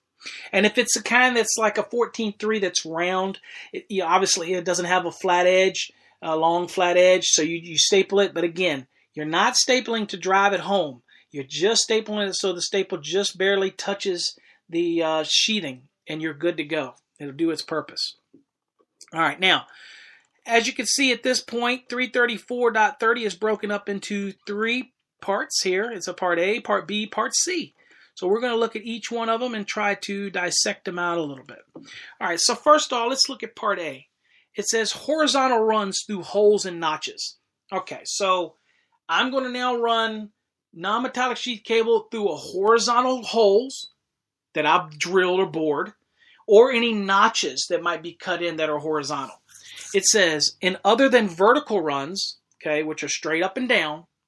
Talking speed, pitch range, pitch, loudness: 185 wpm, 175-230 Hz, 200 Hz, -22 LUFS